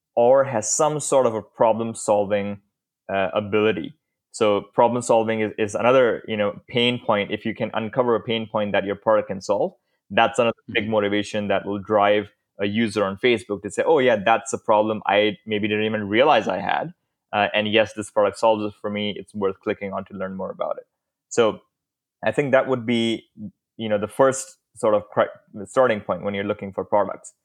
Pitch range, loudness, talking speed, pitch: 100-115 Hz, -22 LUFS, 200 wpm, 105 Hz